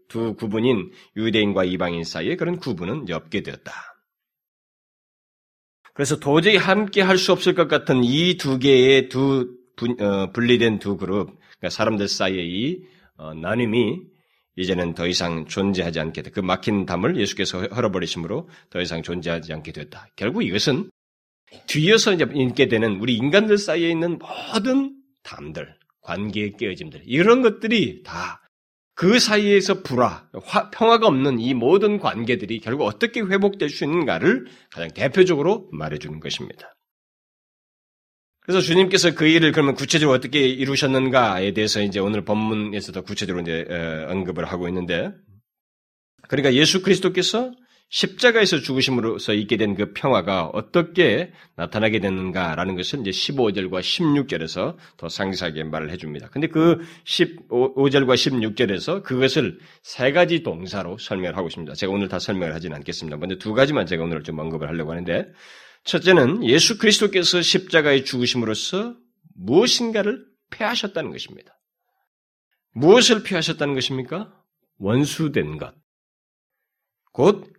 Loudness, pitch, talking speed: -20 LUFS, 125 Hz, 325 characters per minute